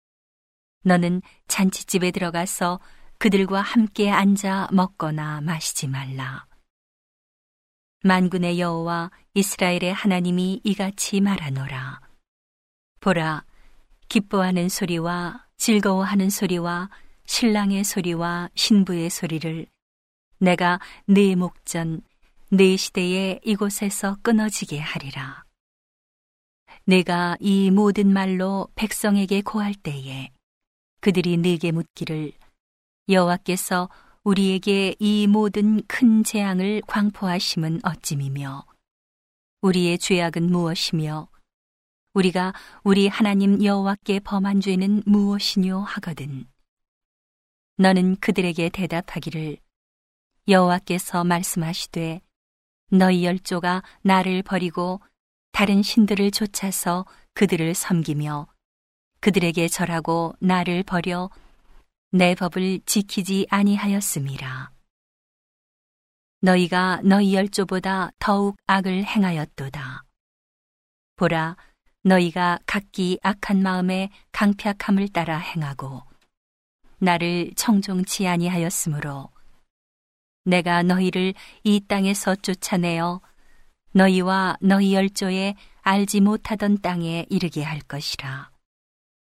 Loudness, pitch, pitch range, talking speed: -22 LUFS, 185 Hz, 170-200 Hz, 225 characters per minute